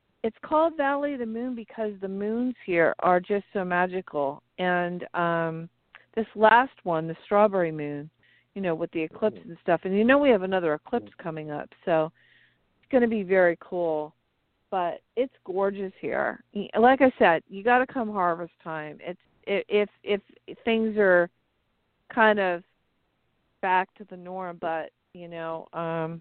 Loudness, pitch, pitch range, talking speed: -26 LUFS, 185 Hz, 165-220 Hz, 165 wpm